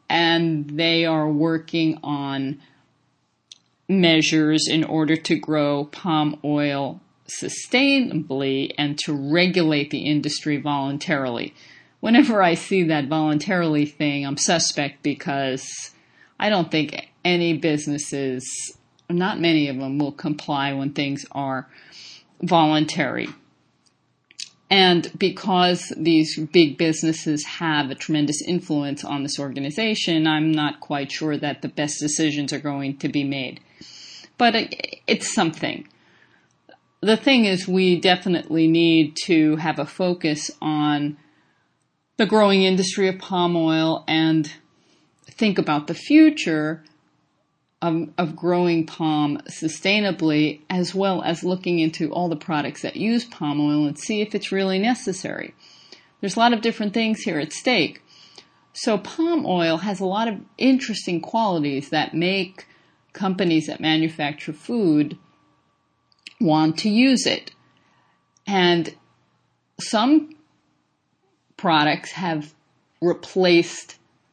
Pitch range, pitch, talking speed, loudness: 150-185 Hz, 160 Hz, 120 wpm, -21 LUFS